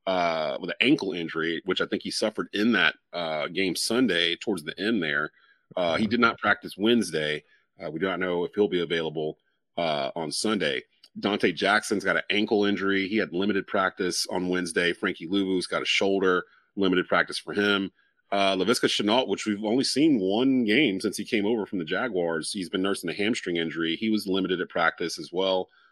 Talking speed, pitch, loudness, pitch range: 205 wpm, 95 Hz, -26 LUFS, 90-105 Hz